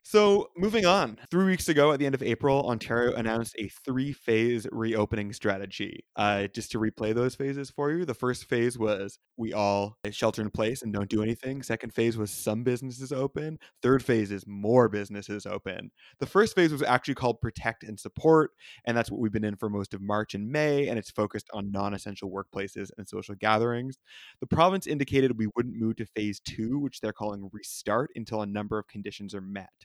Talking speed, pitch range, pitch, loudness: 205 wpm, 105-130 Hz, 115 Hz, -28 LUFS